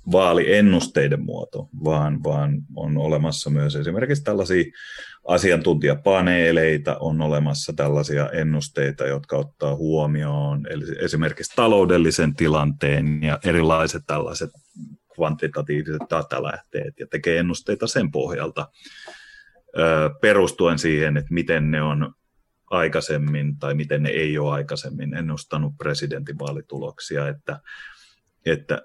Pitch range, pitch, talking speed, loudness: 75-80 Hz, 75 Hz, 100 wpm, -22 LUFS